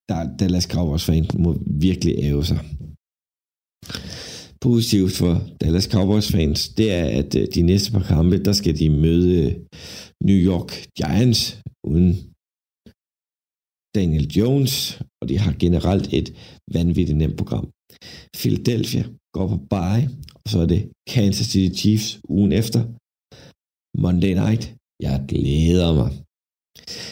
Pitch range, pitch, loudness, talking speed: 80-105 Hz, 90 Hz, -20 LUFS, 120 wpm